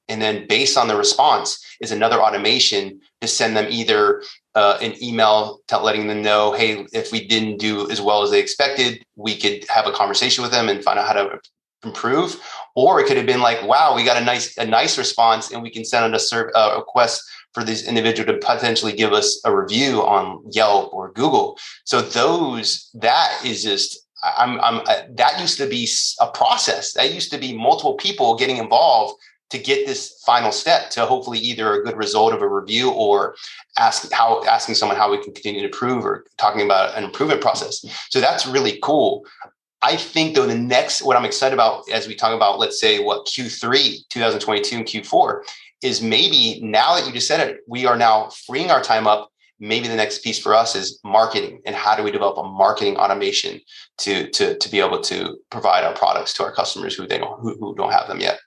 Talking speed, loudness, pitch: 215 wpm, -18 LUFS, 160 Hz